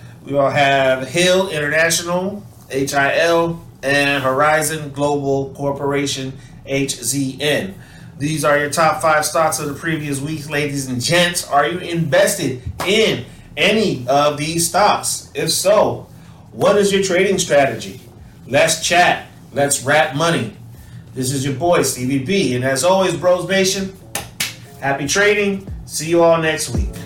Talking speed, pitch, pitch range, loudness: 140 wpm, 145 Hz, 135-170 Hz, -17 LUFS